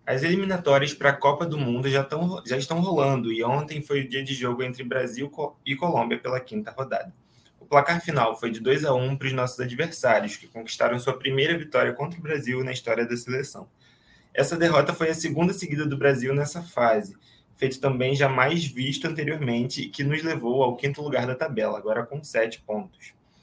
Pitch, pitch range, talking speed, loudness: 135 Hz, 125-155 Hz, 195 wpm, -25 LUFS